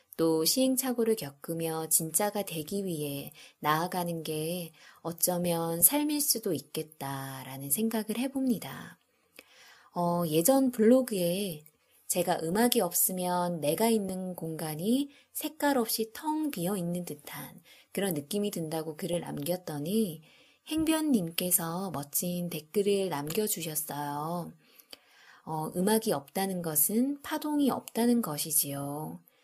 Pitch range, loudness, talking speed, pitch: 160-225 Hz, -30 LUFS, 250 characters per minute, 180 Hz